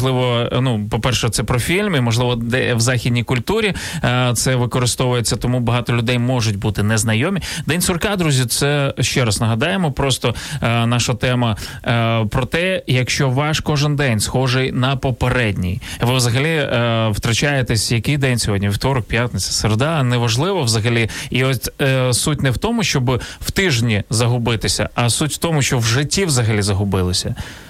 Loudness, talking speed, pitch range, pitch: -17 LUFS, 160 wpm, 115-135 Hz, 125 Hz